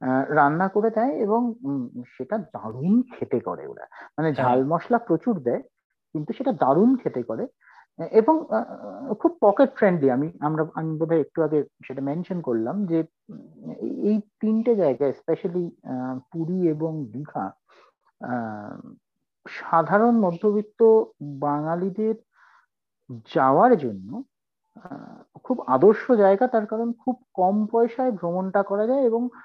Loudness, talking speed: -23 LUFS, 125 wpm